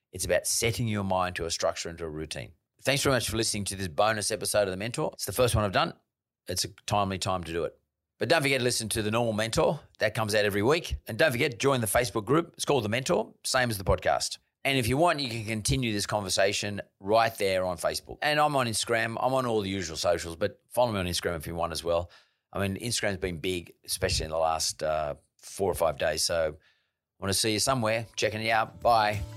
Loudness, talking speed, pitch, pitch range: -28 LUFS, 255 wpm, 105 Hz, 95-120 Hz